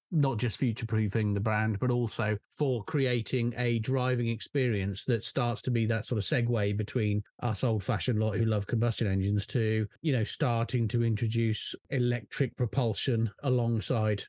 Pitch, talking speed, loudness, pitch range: 115 Hz, 165 wpm, -29 LUFS, 110-125 Hz